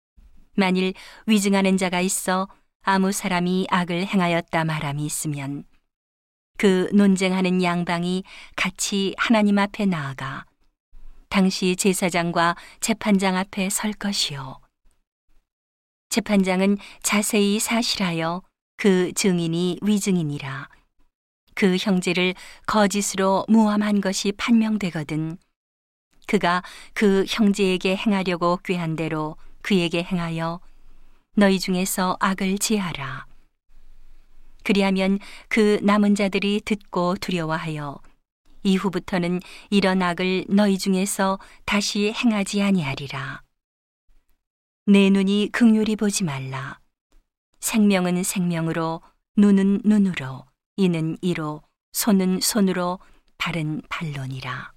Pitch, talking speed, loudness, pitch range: 185 Hz, 225 characters per minute, -22 LUFS, 170-200 Hz